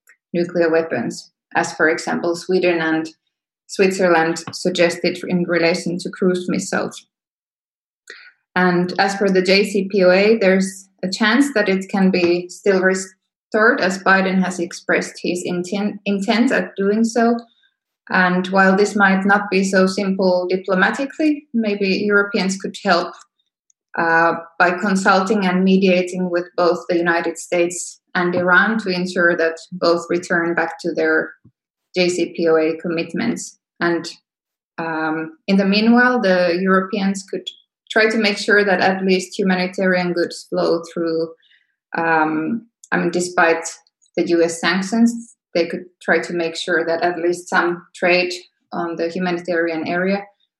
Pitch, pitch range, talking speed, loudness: 180 Hz, 170-200 Hz, 135 wpm, -18 LUFS